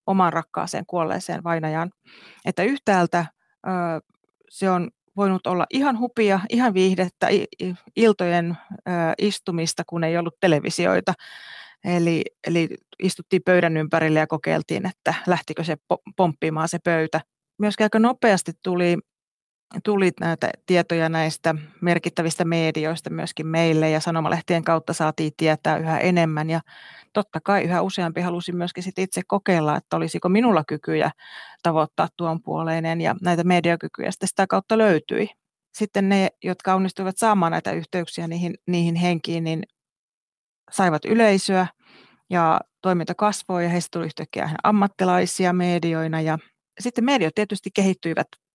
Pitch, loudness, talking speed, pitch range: 175 Hz, -22 LUFS, 125 wpm, 165-195 Hz